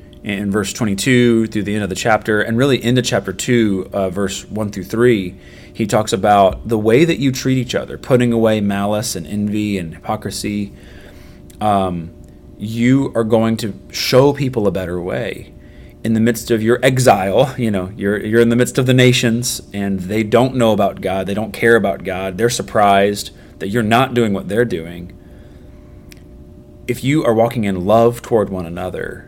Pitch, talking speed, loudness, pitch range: 105 Hz, 185 wpm, -16 LUFS, 95-120 Hz